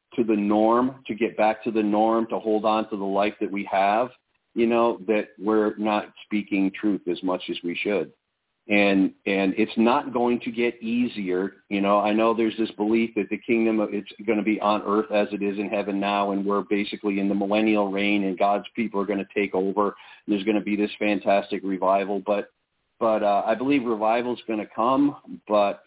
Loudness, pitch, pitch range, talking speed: -24 LUFS, 105 Hz, 100-110 Hz, 220 wpm